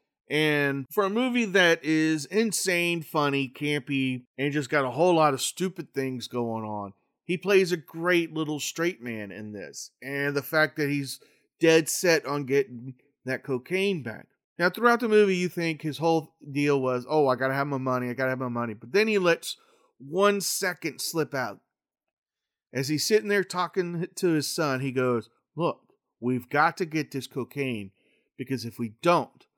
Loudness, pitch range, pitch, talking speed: -26 LUFS, 130-175 Hz, 150 Hz, 190 wpm